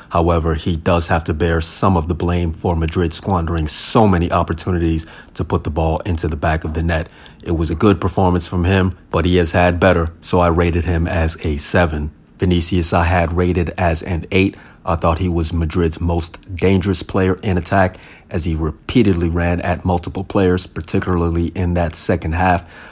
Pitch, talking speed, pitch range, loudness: 85 Hz, 195 wpm, 85-90 Hz, -17 LUFS